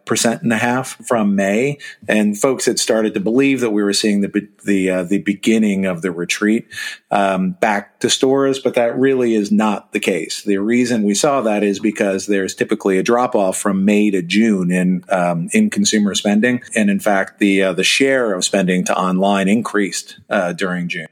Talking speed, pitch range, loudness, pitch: 205 wpm, 95-120 Hz, -16 LUFS, 105 Hz